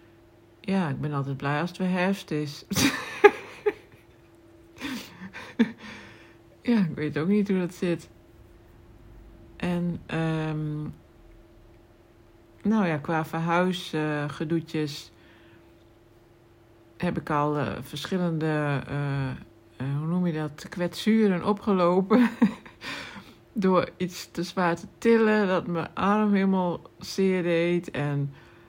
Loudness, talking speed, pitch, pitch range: -26 LUFS, 105 wpm, 155 Hz, 115-185 Hz